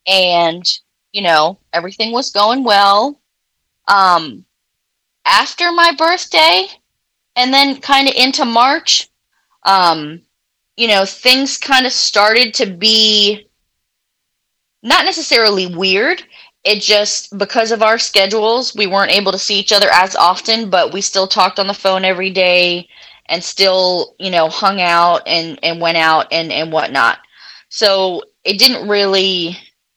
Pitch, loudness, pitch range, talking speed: 200 Hz, -12 LUFS, 185-245 Hz, 140 wpm